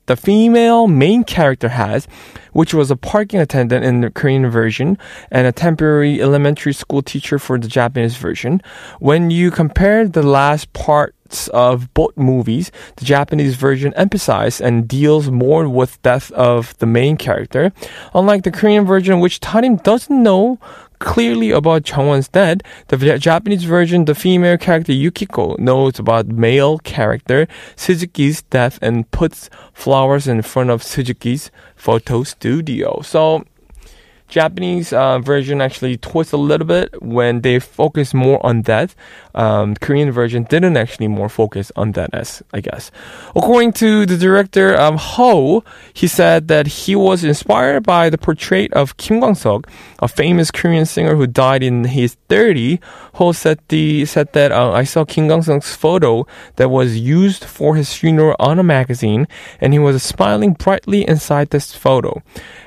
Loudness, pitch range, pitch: -14 LUFS, 130-175 Hz, 145 Hz